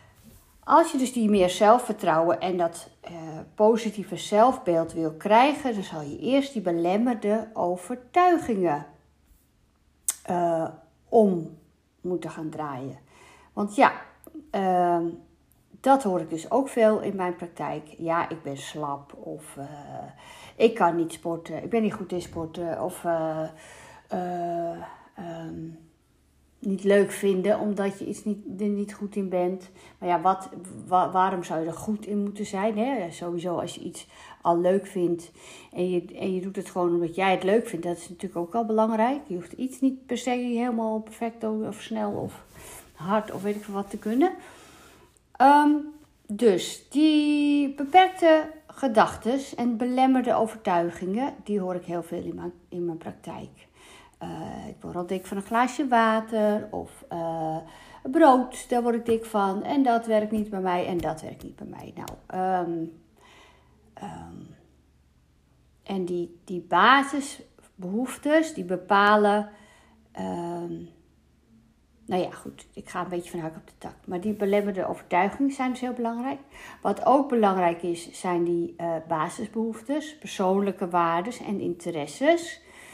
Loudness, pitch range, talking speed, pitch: -25 LUFS, 170-230 Hz, 155 wpm, 190 Hz